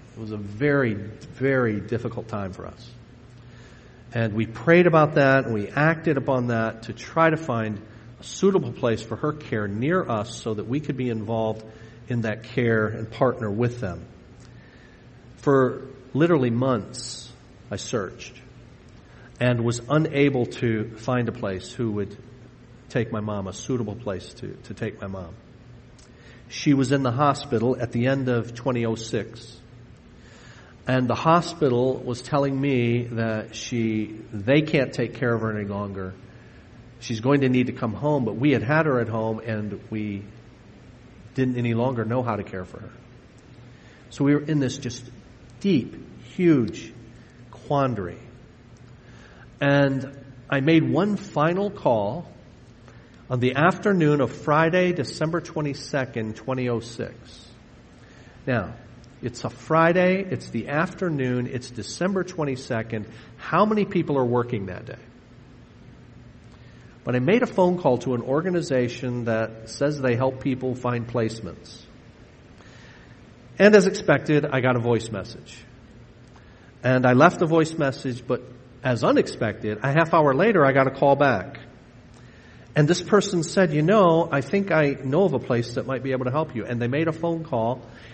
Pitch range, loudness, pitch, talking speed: 115-140 Hz, -23 LUFS, 125 Hz, 155 wpm